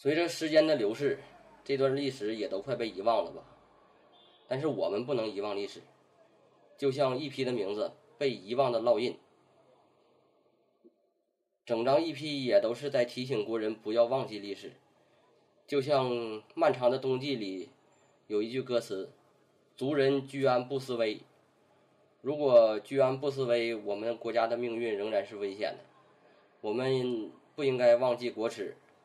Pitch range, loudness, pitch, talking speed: 115-140 Hz, -31 LUFS, 130 Hz, 225 characters per minute